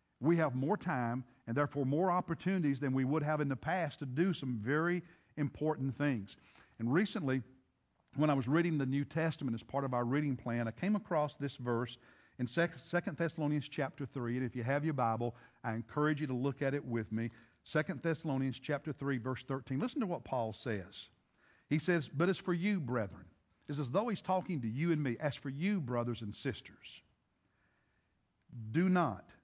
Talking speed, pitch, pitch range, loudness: 195 wpm, 140 Hz, 120-160 Hz, -36 LUFS